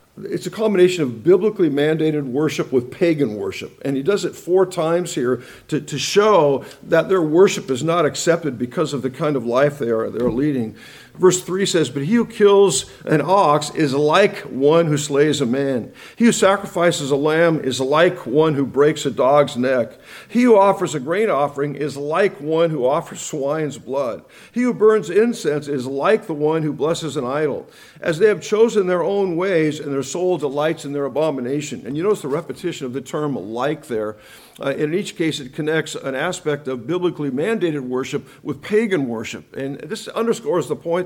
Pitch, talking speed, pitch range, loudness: 155 Hz, 195 wpm, 140-180 Hz, -19 LUFS